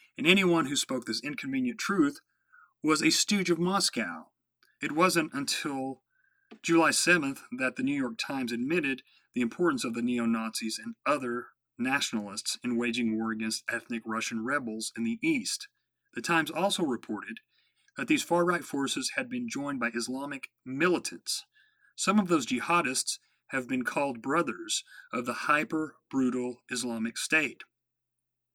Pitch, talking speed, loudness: 150 Hz, 150 wpm, -29 LUFS